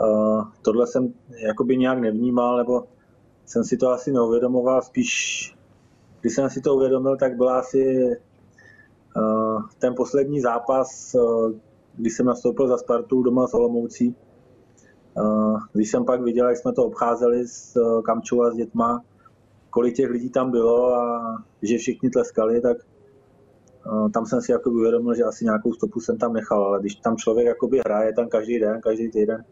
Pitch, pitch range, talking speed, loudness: 120 Hz, 110-125 Hz, 165 wpm, -22 LUFS